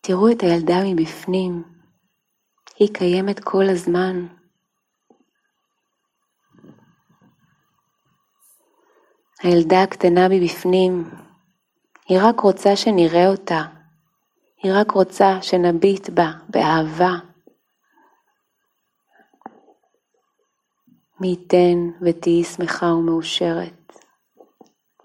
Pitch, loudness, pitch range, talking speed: 185 Hz, -18 LUFS, 175-195 Hz, 65 wpm